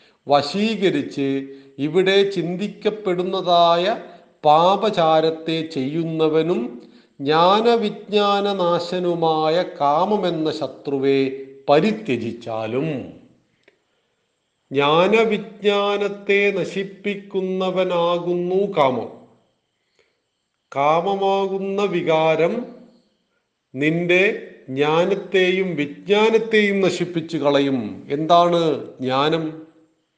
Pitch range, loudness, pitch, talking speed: 150-195 Hz, -19 LUFS, 175 Hz, 45 wpm